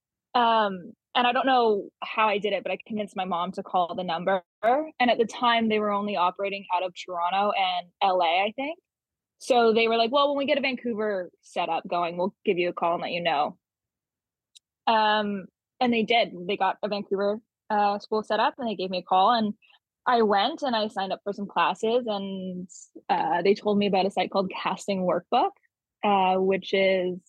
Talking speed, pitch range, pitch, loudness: 215 wpm, 185-230 Hz, 205 Hz, -25 LUFS